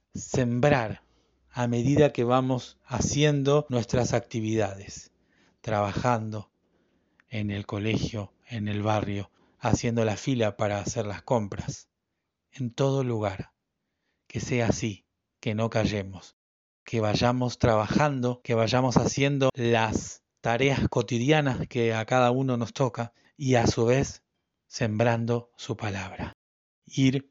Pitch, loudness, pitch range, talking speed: 115 Hz, -27 LUFS, 105-125 Hz, 120 wpm